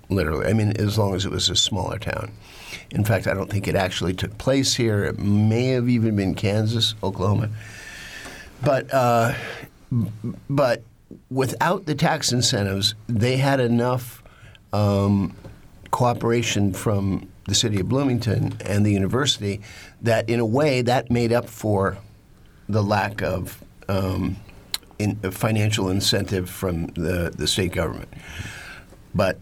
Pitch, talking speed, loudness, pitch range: 105 Hz, 145 wpm, -22 LUFS, 95-120 Hz